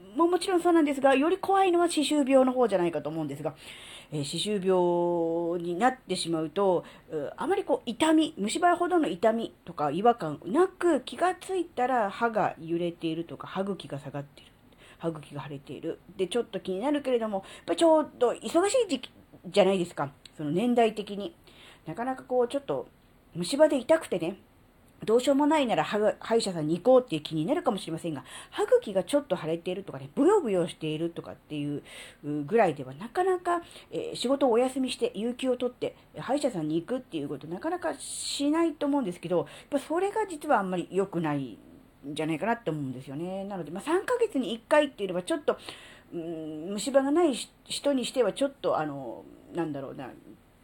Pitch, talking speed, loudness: 210 Hz, 415 characters per minute, -28 LUFS